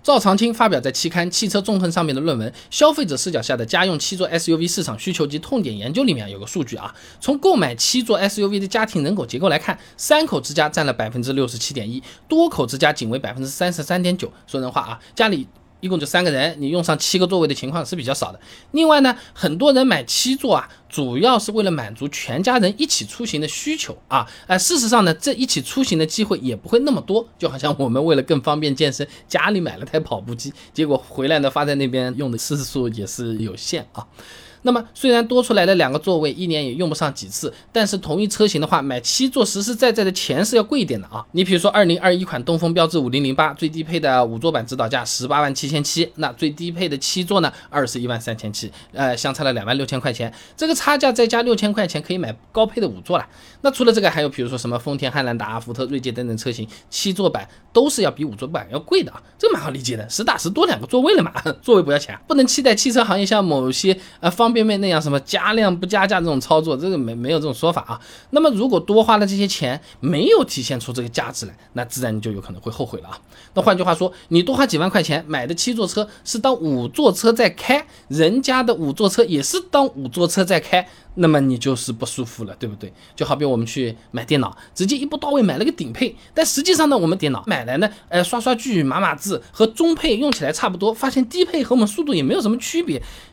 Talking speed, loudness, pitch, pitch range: 365 characters per minute, -19 LUFS, 170 Hz, 135-220 Hz